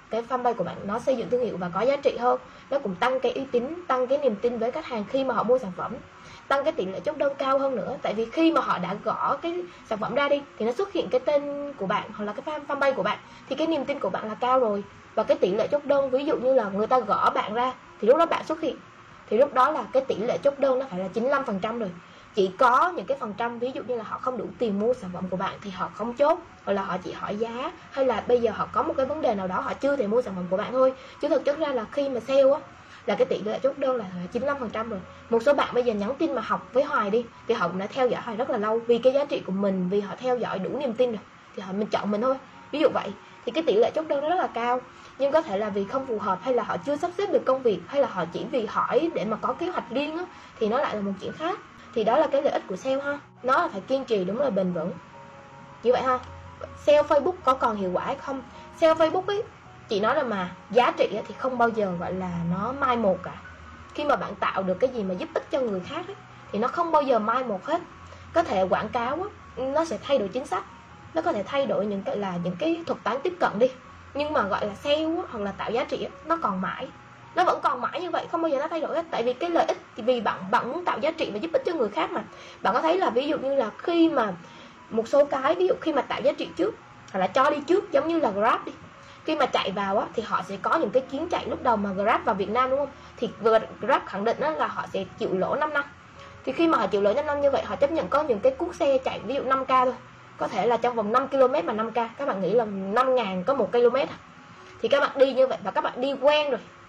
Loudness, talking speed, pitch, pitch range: -26 LUFS, 300 wpm, 255 Hz, 220-290 Hz